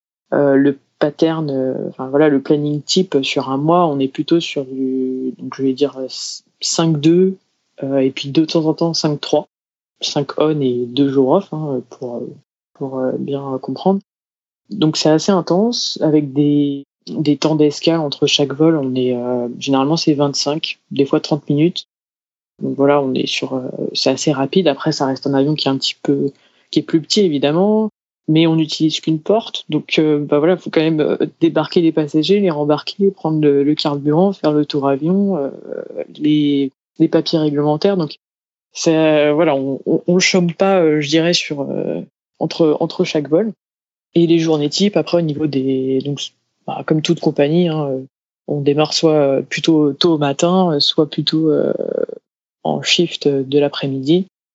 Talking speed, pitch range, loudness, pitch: 185 wpm, 140-165 Hz, -16 LUFS, 155 Hz